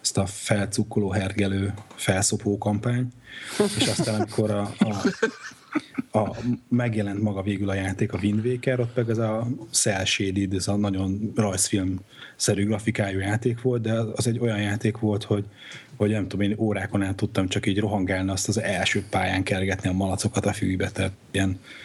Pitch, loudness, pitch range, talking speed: 105 Hz, -25 LUFS, 100-115 Hz, 170 wpm